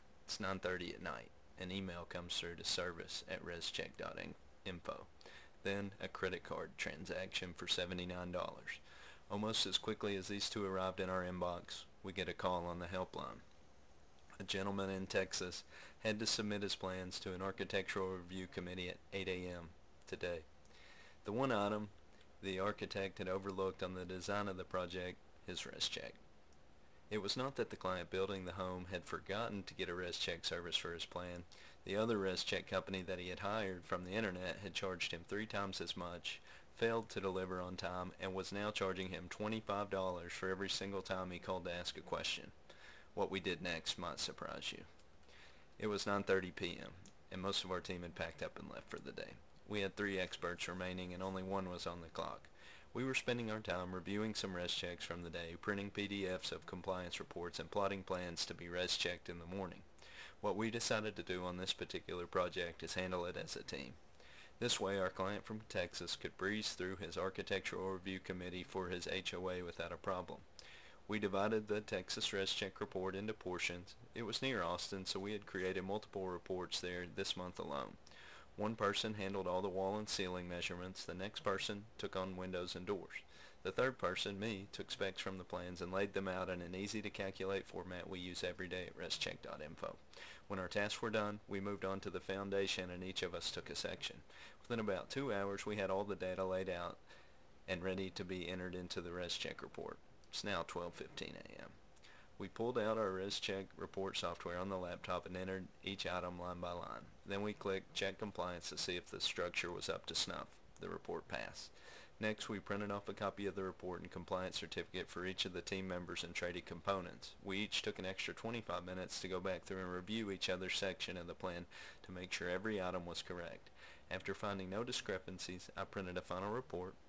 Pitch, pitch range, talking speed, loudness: 95 Hz, 90-100 Hz, 200 wpm, -43 LUFS